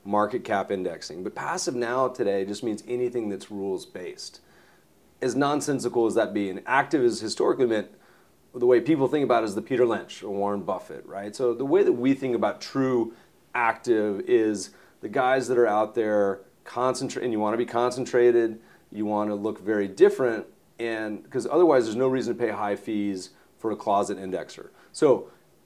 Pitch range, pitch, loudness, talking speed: 105-130 Hz, 120 Hz, -25 LUFS, 185 wpm